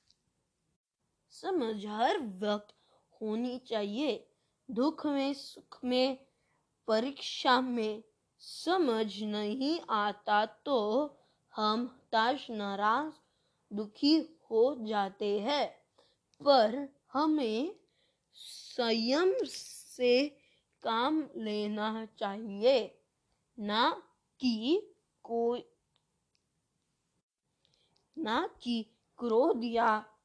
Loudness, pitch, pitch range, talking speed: -32 LUFS, 235 Hz, 215-280 Hz, 70 wpm